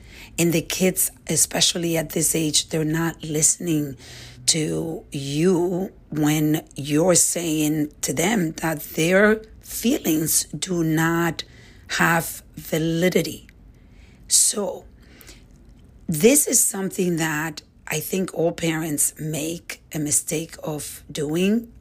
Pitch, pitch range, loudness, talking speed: 160 Hz, 155-175 Hz, -21 LUFS, 105 wpm